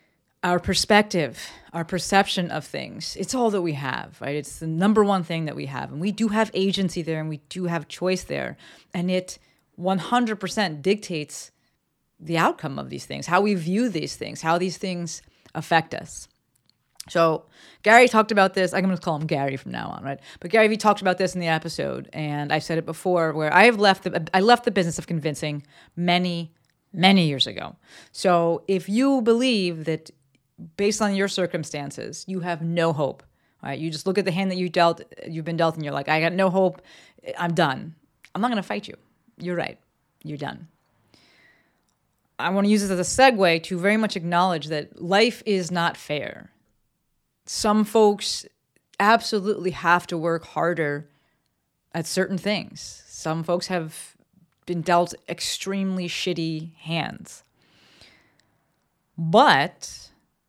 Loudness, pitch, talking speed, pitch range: -23 LUFS, 175 Hz, 170 wpm, 160-195 Hz